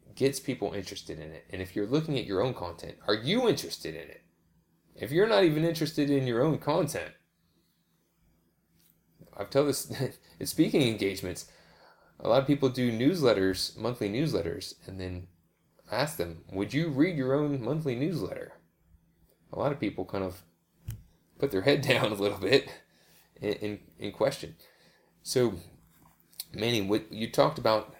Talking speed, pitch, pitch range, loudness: 160 wpm, 110 Hz, 95-140 Hz, -29 LUFS